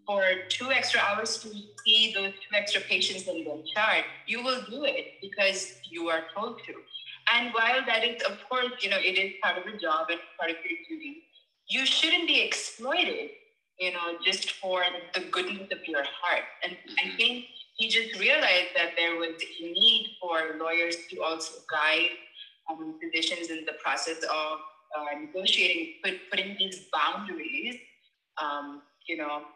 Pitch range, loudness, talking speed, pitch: 170-230 Hz, -27 LUFS, 175 wpm, 190 Hz